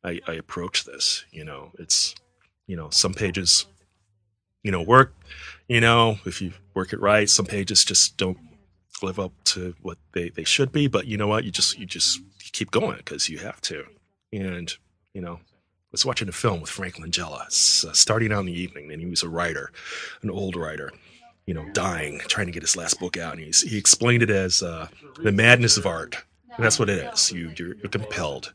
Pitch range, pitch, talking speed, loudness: 90-105 Hz, 95 Hz, 210 wpm, -21 LUFS